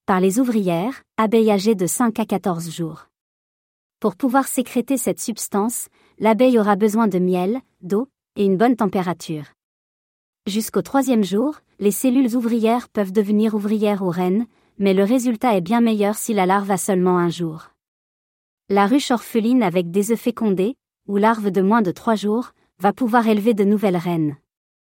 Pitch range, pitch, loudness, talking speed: 190-235 Hz, 210 Hz, -19 LUFS, 165 wpm